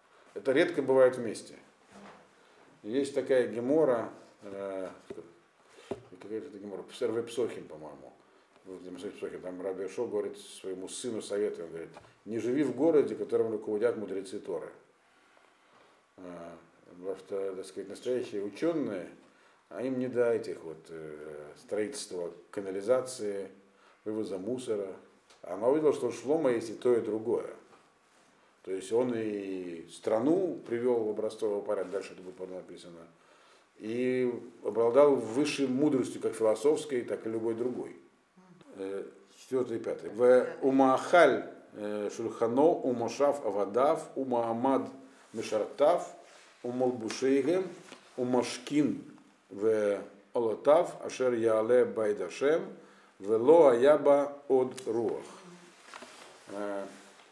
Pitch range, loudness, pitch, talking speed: 100-150 Hz, -30 LUFS, 125 Hz, 105 wpm